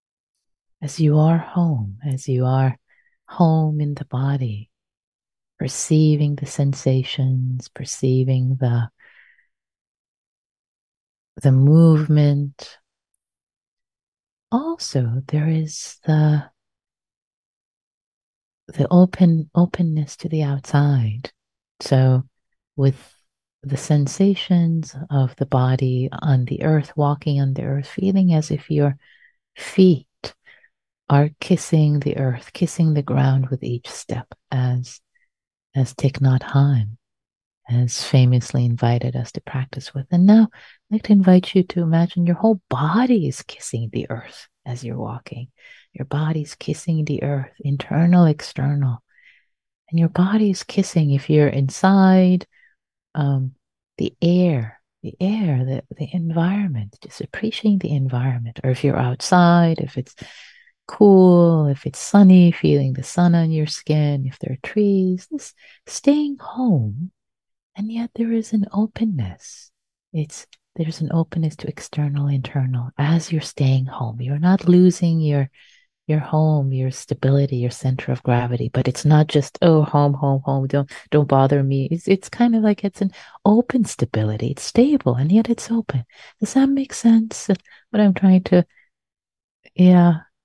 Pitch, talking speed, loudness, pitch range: 150 Hz, 135 wpm, -19 LUFS, 130-180 Hz